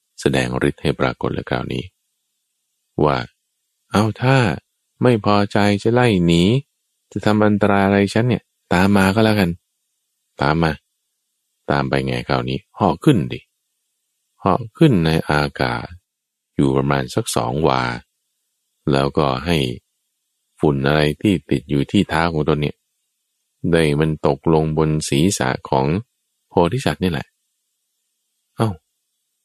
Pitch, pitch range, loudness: 80 Hz, 70-100 Hz, -18 LUFS